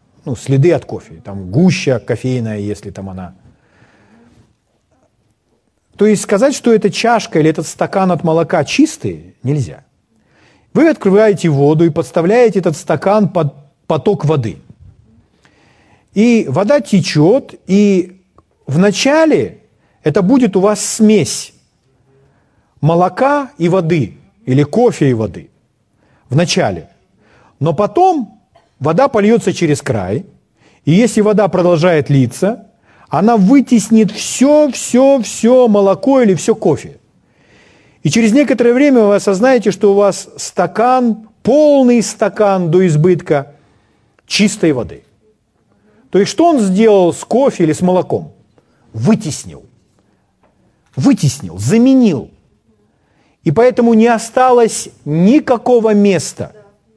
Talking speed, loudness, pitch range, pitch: 110 wpm, -12 LUFS, 145-225 Hz, 190 Hz